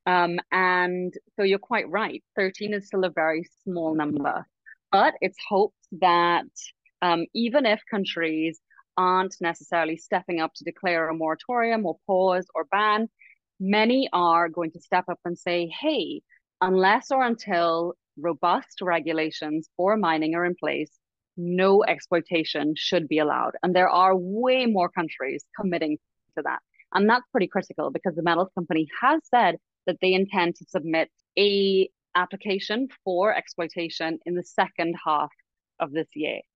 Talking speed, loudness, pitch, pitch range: 150 wpm, -25 LUFS, 180 Hz, 165-195 Hz